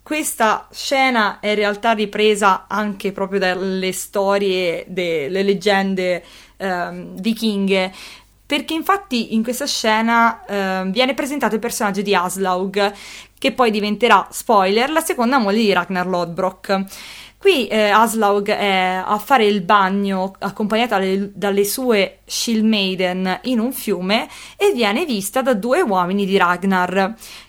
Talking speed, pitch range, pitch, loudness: 130 wpm, 190-230 Hz, 200 Hz, -18 LUFS